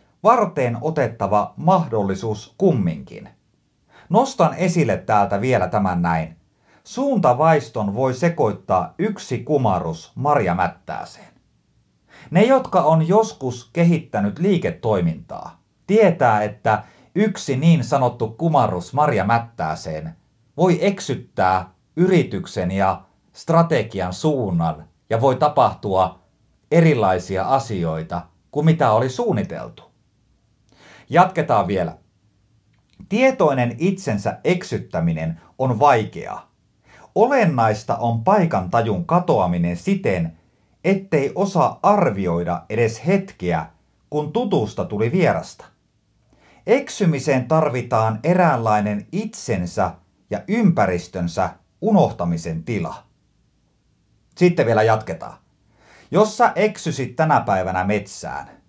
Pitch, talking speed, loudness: 120 Hz, 85 wpm, -19 LUFS